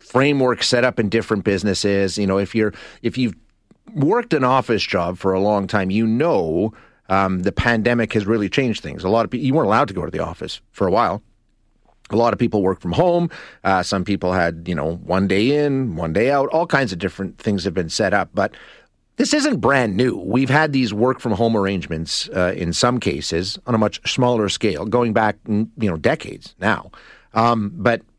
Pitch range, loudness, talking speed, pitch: 95-125 Hz, -19 LUFS, 215 wpm, 110 Hz